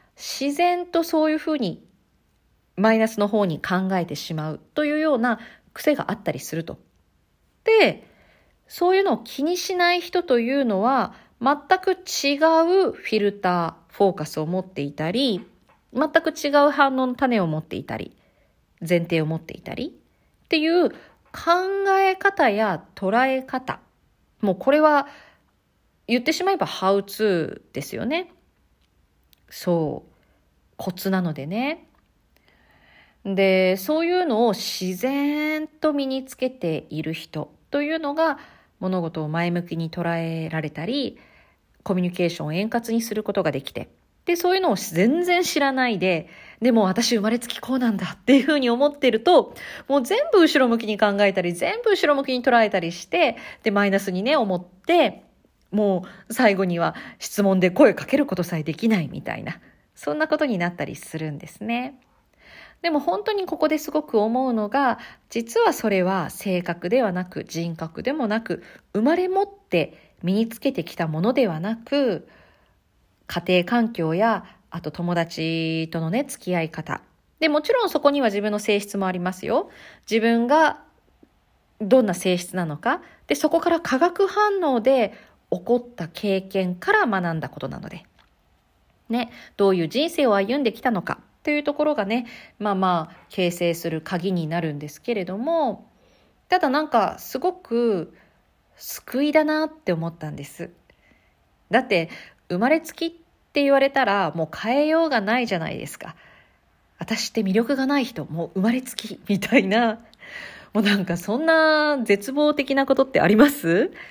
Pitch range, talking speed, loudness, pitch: 180-285 Hz, 300 characters per minute, -22 LUFS, 220 Hz